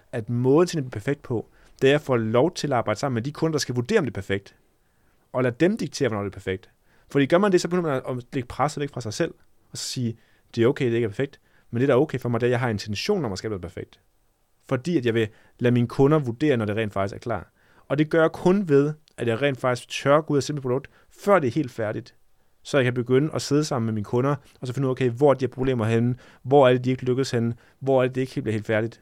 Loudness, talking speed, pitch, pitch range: -24 LUFS, 305 wpm, 125 Hz, 115-145 Hz